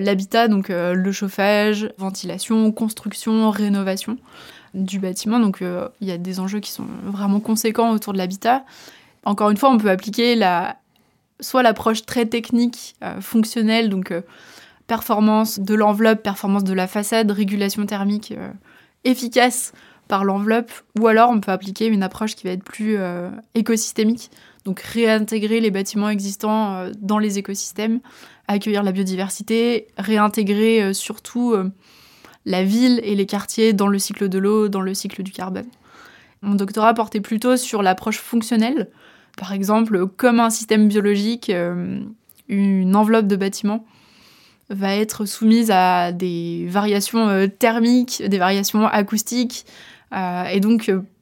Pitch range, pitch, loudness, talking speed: 195-225 Hz, 210 Hz, -19 LUFS, 145 wpm